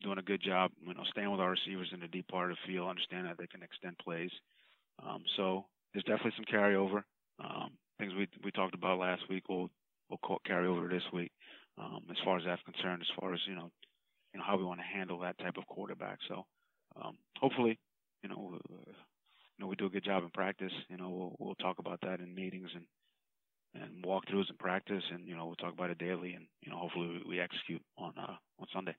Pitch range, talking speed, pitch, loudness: 90-95 Hz, 235 wpm, 95 Hz, -39 LUFS